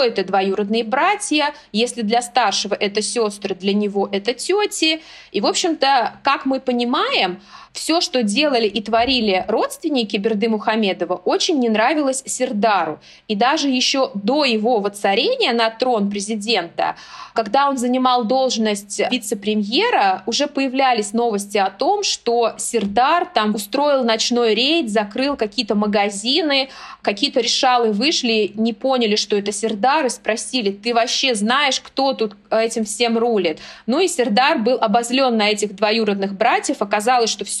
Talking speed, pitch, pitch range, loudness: 140 wpm, 235 Hz, 215-270 Hz, -18 LUFS